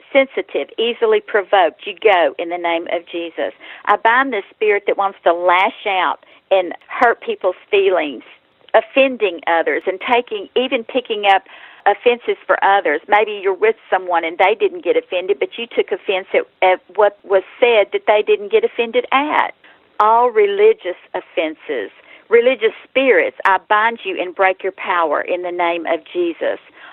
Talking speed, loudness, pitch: 165 wpm, -17 LUFS, 240 Hz